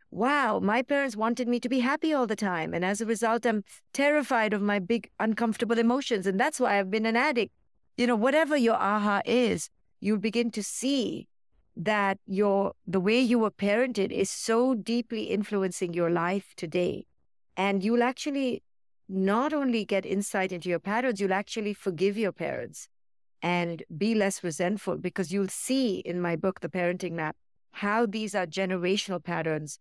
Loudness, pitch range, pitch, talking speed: -28 LUFS, 190-235 Hz, 210 Hz, 175 wpm